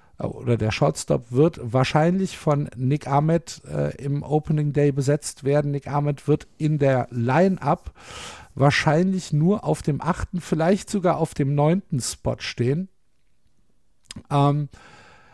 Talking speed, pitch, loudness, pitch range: 130 wpm, 145 Hz, -23 LUFS, 140-160 Hz